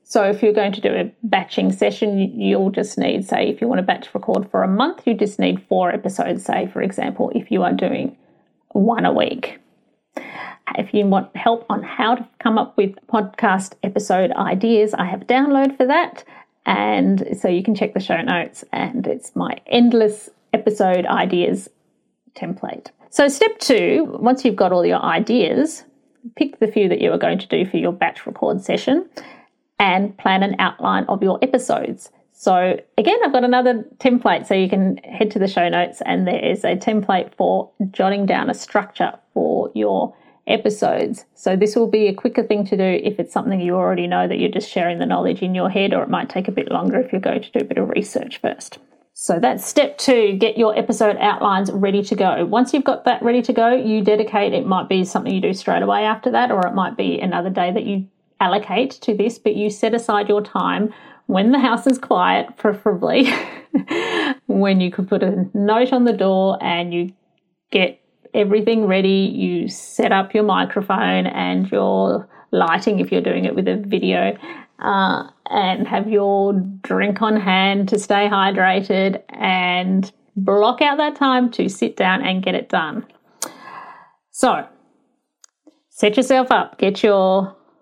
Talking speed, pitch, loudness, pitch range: 190 wpm, 210 Hz, -18 LUFS, 190-240 Hz